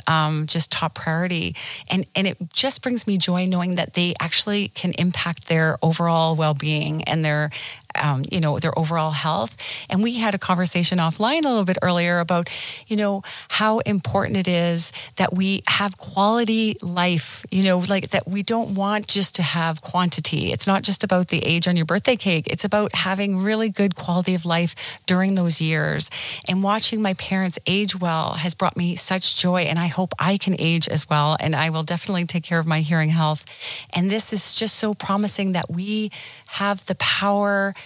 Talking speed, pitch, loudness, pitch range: 195 wpm, 180 Hz, -20 LUFS, 160-195 Hz